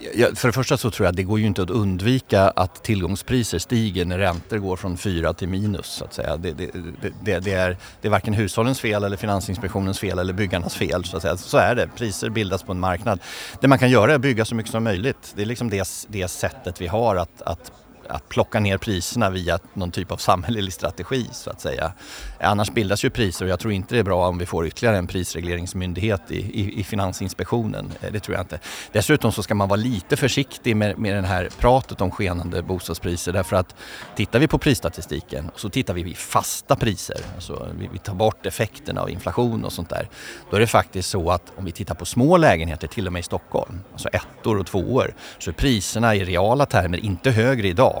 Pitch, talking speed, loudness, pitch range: 100 Hz, 230 wpm, -22 LUFS, 90-115 Hz